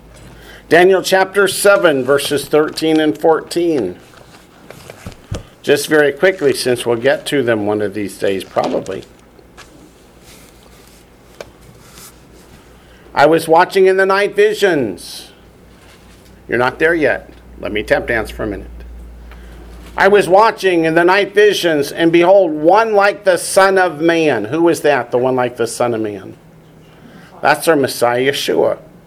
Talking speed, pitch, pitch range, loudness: 140 wpm, 160 Hz, 120-190 Hz, -13 LUFS